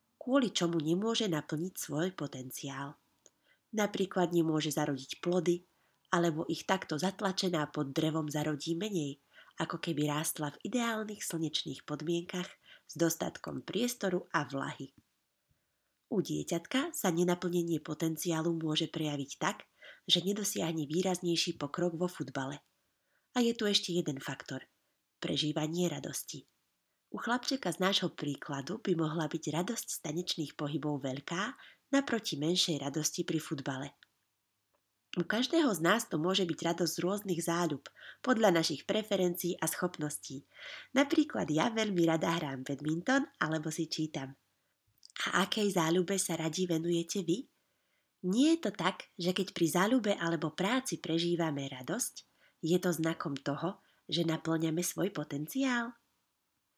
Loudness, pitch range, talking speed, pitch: -33 LUFS, 155-185 Hz, 130 wpm, 170 Hz